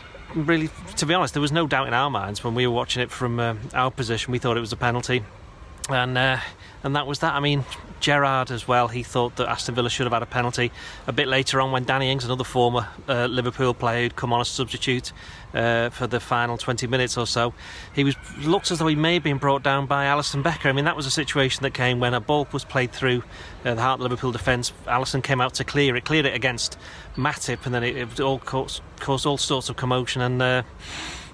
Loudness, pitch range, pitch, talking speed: -23 LUFS, 120-140 Hz, 125 Hz, 245 wpm